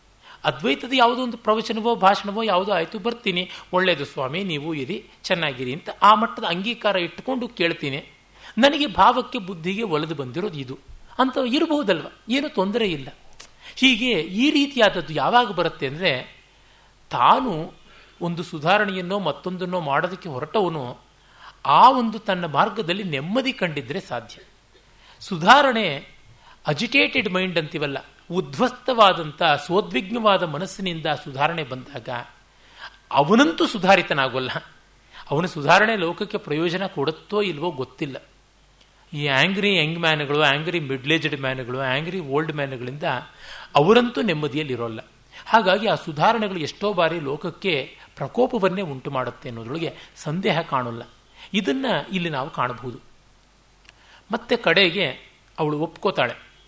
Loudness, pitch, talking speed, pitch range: -22 LUFS, 180 Hz, 105 wpm, 145-215 Hz